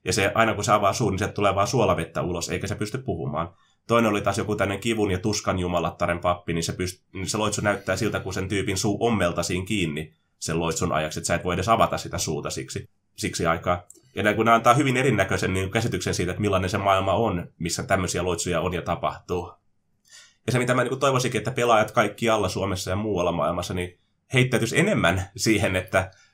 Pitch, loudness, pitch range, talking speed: 100 Hz, -24 LUFS, 90-110 Hz, 210 wpm